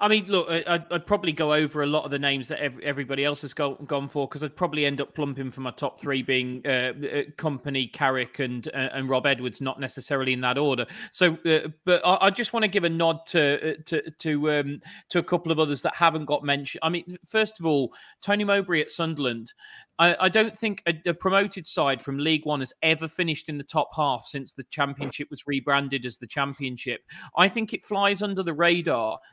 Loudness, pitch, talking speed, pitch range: -25 LUFS, 150 Hz, 225 wpm, 140-175 Hz